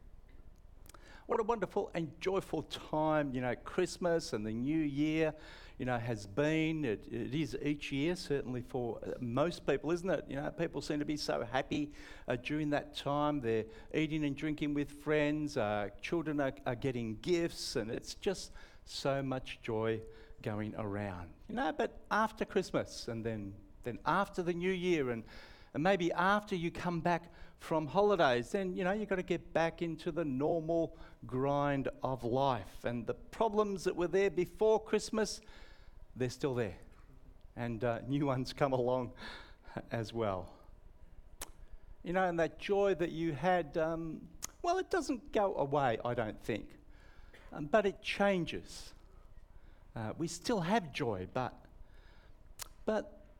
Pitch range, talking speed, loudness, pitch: 115-175 Hz, 160 wpm, -36 LUFS, 145 Hz